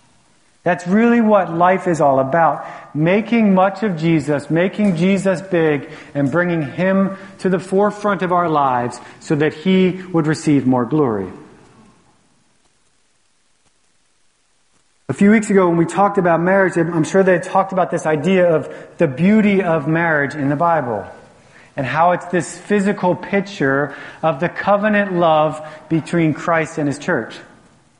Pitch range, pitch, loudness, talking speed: 155-190 Hz, 170 Hz, -17 LUFS, 150 wpm